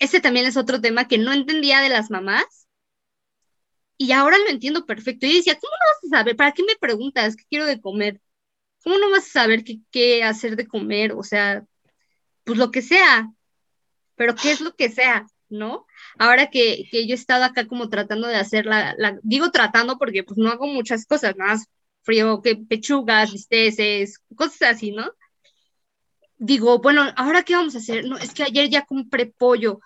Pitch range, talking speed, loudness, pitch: 220-285 Hz, 195 wpm, -18 LUFS, 245 Hz